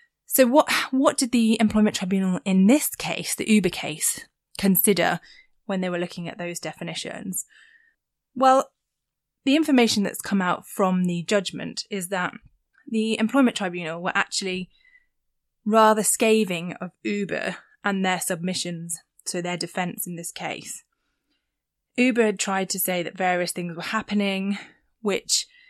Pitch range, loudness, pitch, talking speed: 180-240 Hz, -23 LUFS, 200 Hz, 140 wpm